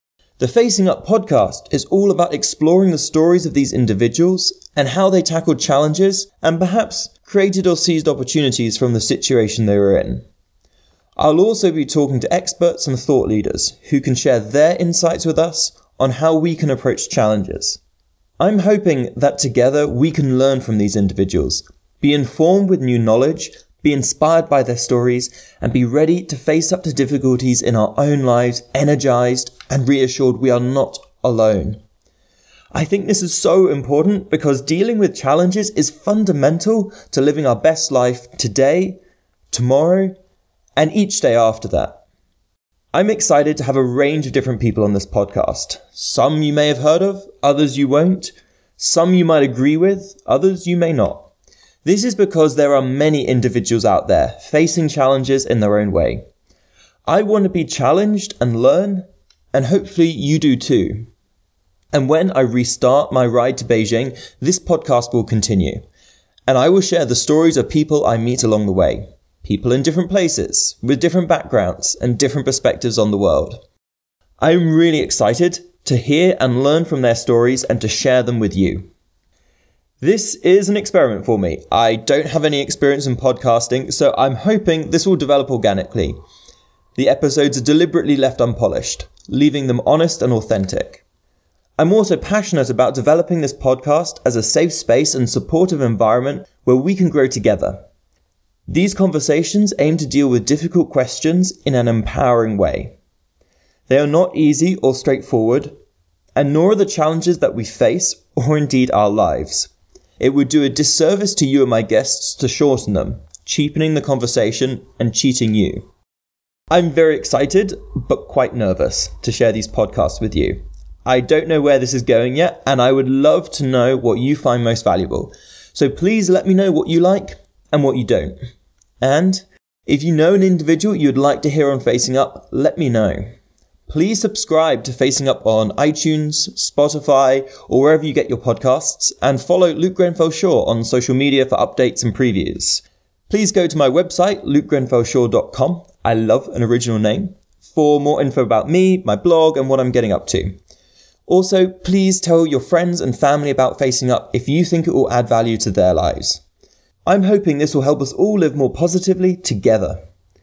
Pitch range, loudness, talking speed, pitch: 120-170 Hz, -16 LUFS, 175 wpm, 140 Hz